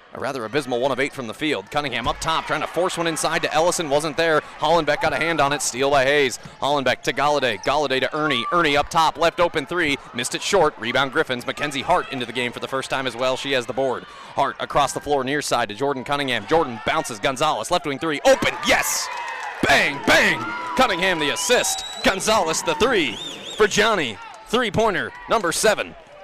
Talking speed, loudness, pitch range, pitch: 215 wpm, -21 LUFS, 135-165 Hz, 145 Hz